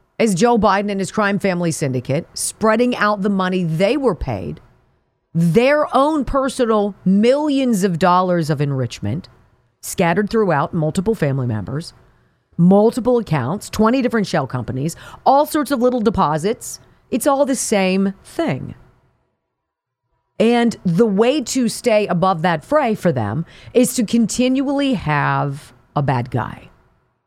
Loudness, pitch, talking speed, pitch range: -18 LUFS, 200 Hz, 135 wpm, 155-240 Hz